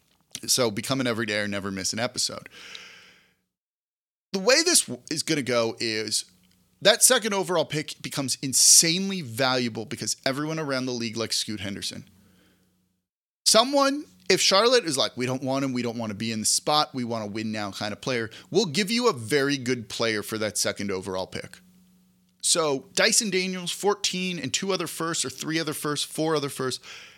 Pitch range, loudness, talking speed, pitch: 110-175 Hz, -24 LUFS, 185 wpm, 135 Hz